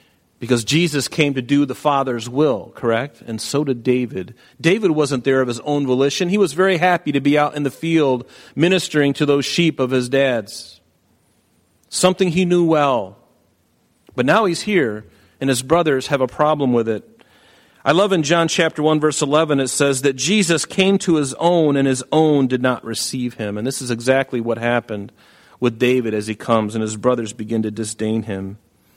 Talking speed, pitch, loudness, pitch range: 195 wpm, 135 Hz, -18 LUFS, 120-155 Hz